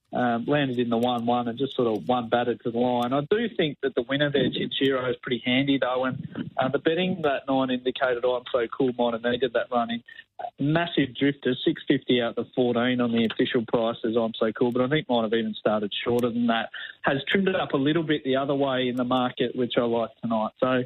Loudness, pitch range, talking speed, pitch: -25 LUFS, 120-140 Hz, 245 wpm, 125 Hz